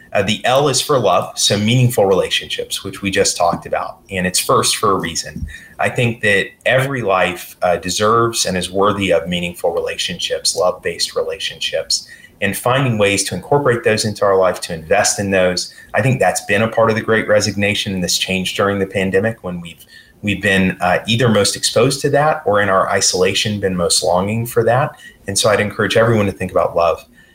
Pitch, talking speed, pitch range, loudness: 105 Hz, 205 wpm, 95-115 Hz, -16 LUFS